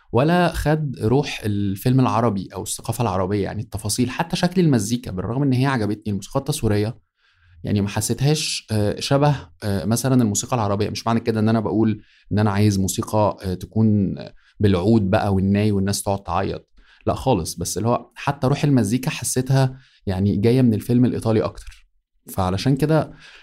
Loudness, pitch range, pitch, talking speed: -21 LUFS, 100-130 Hz, 110 Hz, 155 wpm